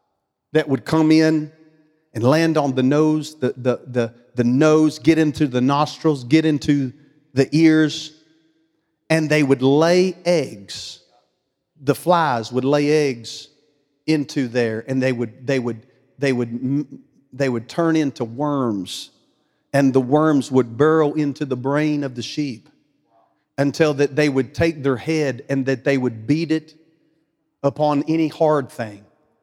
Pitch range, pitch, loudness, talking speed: 130-155 Hz, 145 Hz, -19 LUFS, 155 wpm